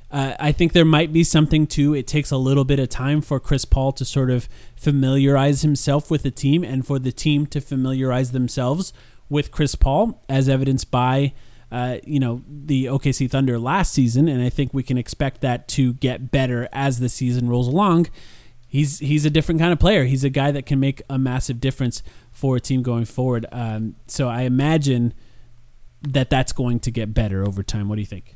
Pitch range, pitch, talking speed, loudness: 125-145 Hz, 135 Hz, 210 wpm, -20 LUFS